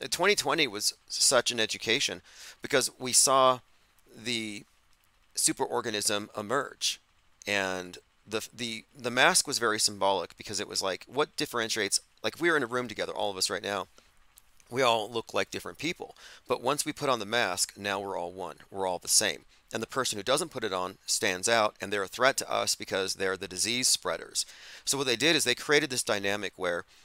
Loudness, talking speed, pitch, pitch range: -28 LUFS, 195 wpm, 115 Hz, 100-125 Hz